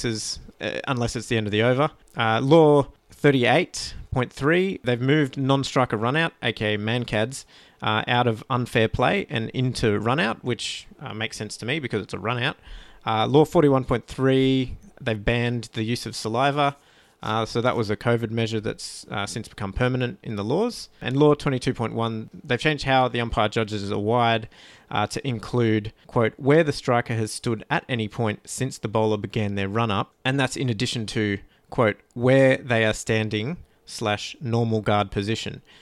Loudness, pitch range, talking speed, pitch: -24 LUFS, 110-130 Hz, 175 wpm, 120 Hz